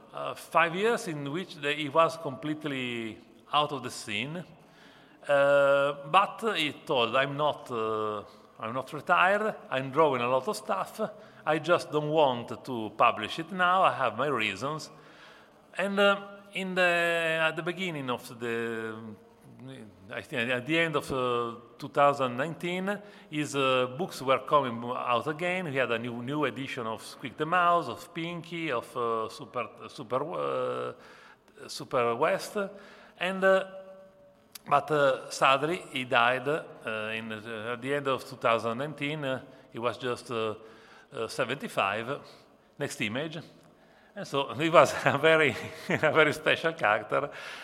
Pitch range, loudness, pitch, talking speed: 120-170 Hz, -29 LUFS, 145 Hz, 150 wpm